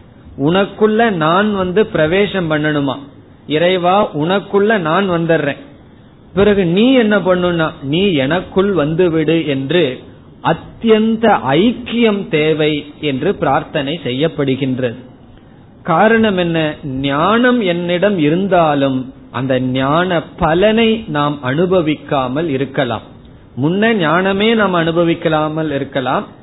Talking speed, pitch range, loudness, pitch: 85 wpm, 140-195 Hz, -14 LUFS, 160 Hz